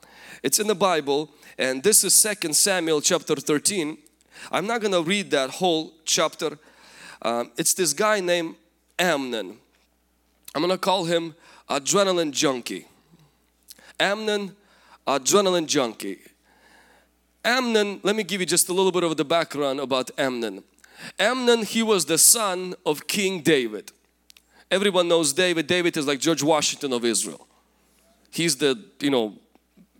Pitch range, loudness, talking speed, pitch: 145-190 Hz, -22 LUFS, 140 wpm, 170 Hz